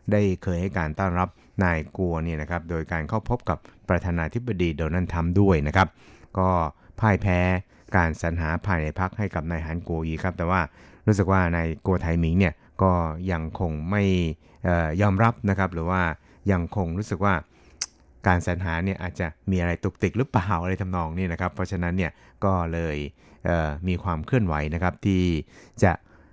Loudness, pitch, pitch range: -25 LUFS, 90 Hz, 85-95 Hz